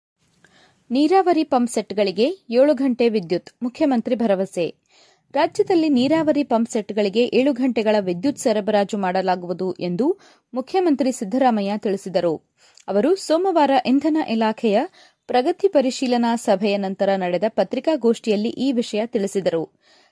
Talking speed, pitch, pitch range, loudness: 95 wpm, 240 Hz, 205-285 Hz, -20 LUFS